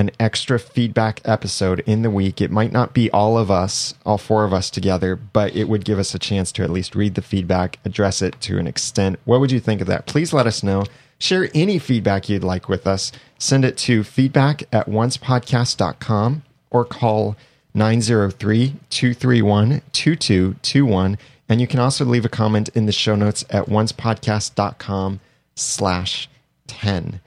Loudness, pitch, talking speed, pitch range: -19 LUFS, 110 Hz, 170 wpm, 100-125 Hz